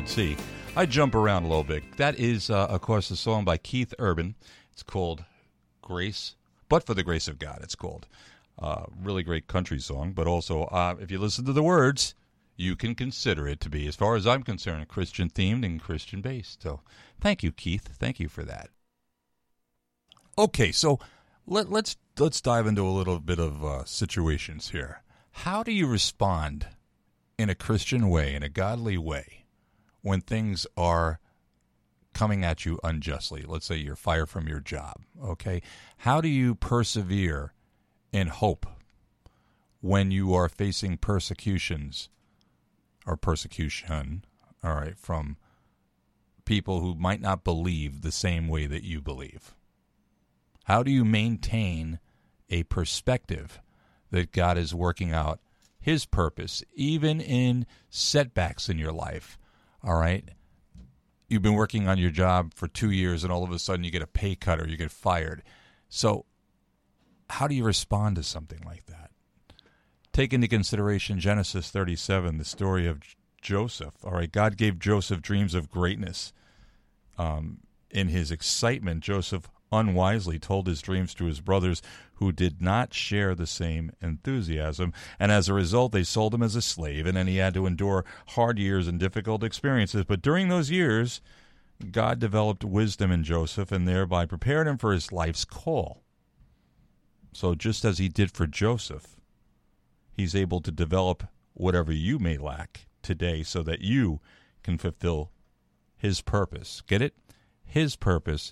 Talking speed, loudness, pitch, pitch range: 160 wpm, -28 LUFS, 95 Hz, 80-105 Hz